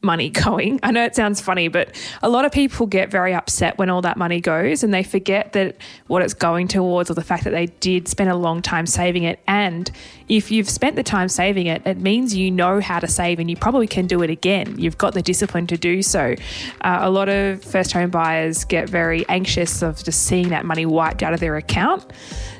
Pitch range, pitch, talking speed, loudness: 170-200 Hz, 180 Hz, 235 wpm, -19 LUFS